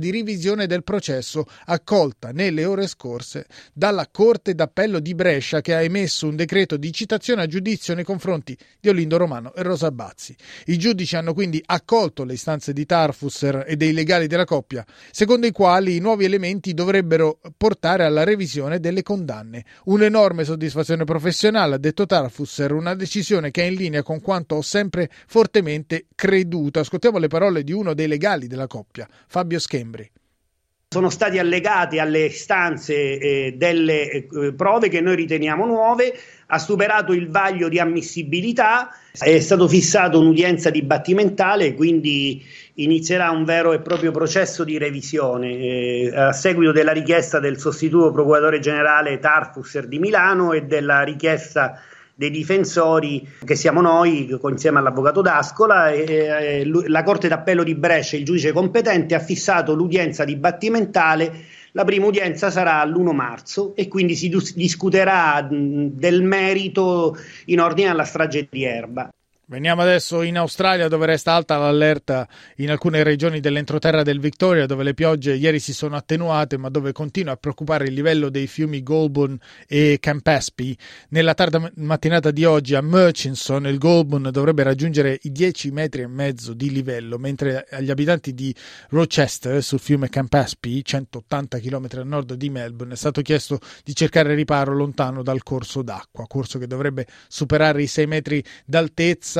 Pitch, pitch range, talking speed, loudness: 160 Hz, 140-175 Hz, 155 wpm, -19 LUFS